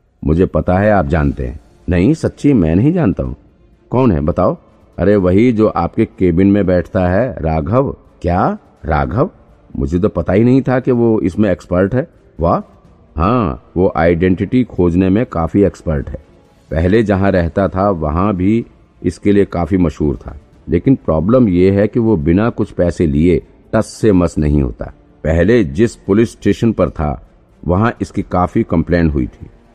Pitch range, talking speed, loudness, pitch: 85-105 Hz, 170 wpm, -14 LUFS, 95 Hz